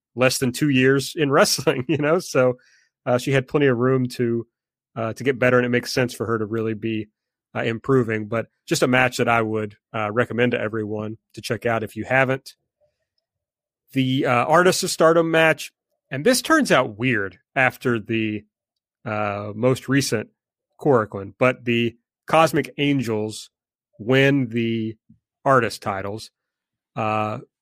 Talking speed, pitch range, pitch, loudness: 160 wpm, 110-135 Hz, 125 Hz, -21 LUFS